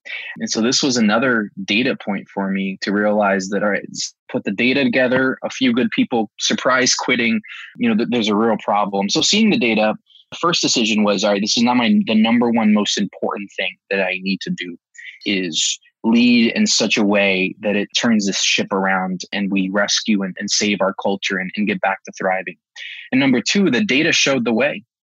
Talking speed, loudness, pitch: 215 wpm, -17 LUFS, 110 Hz